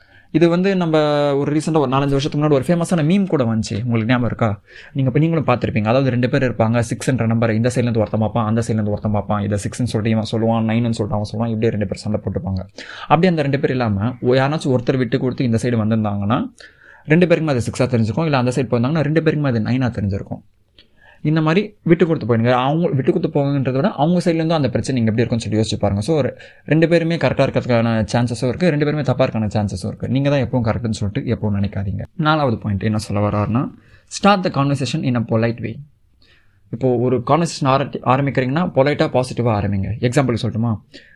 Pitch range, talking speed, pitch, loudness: 110-145 Hz, 180 wpm, 125 Hz, -18 LUFS